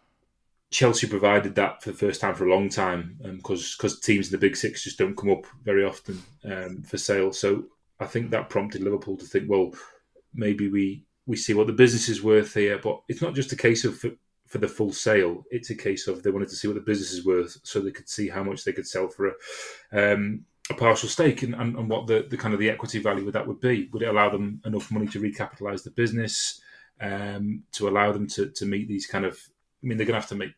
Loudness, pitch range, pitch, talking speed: -26 LUFS, 100-115 Hz, 105 Hz, 255 wpm